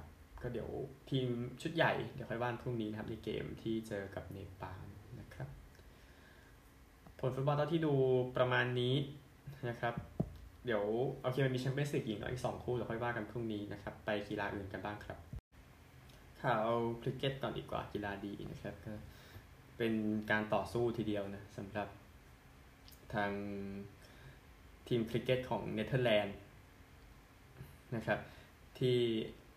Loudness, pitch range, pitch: -39 LUFS, 100-125 Hz, 110 Hz